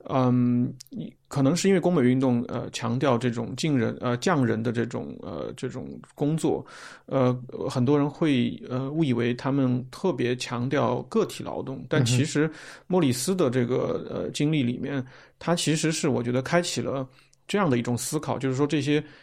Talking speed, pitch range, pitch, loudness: 260 characters per minute, 125-150 Hz, 130 Hz, -26 LUFS